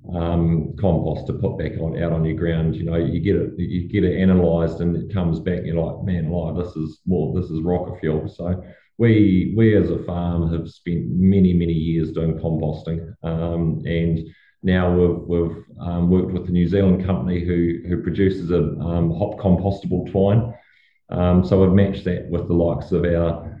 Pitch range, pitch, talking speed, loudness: 85-90 Hz, 85 Hz, 200 wpm, -21 LUFS